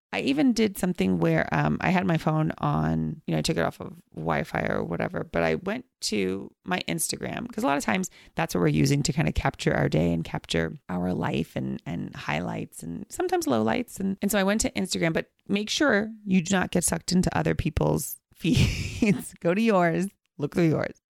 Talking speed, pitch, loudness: 220 wpm, 175 Hz, -26 LUFS